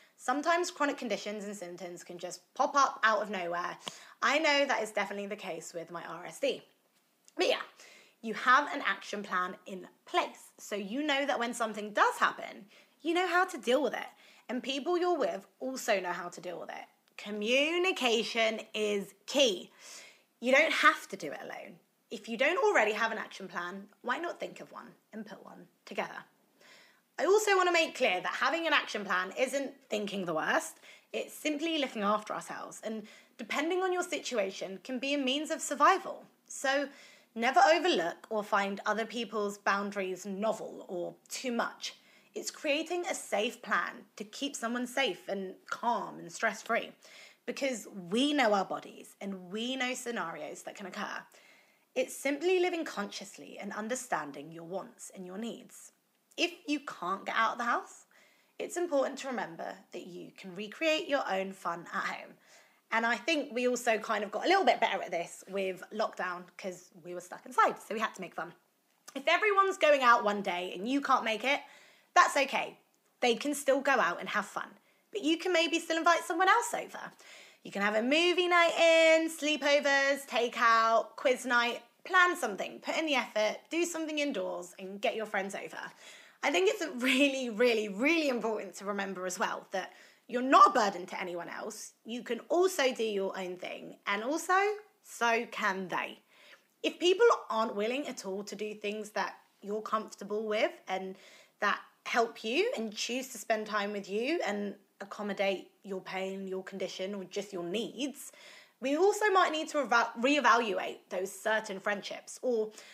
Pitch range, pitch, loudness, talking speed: 200-295 Hz, 235 Hz, -31 LUFS, 180 wpm